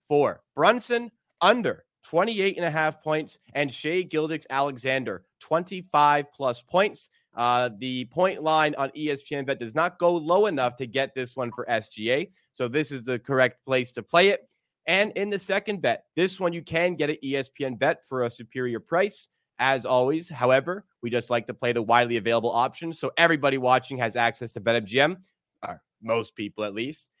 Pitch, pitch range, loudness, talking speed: 140 Hz, 125-165 Hz, -25 LUFS, 185 wpm